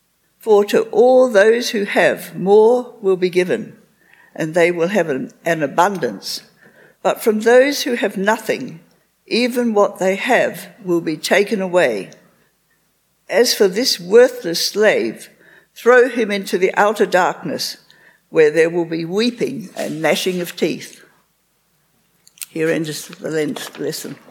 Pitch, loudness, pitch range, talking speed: 205 Hz, -16 LUFS, 180-245 Hz, 135 wpm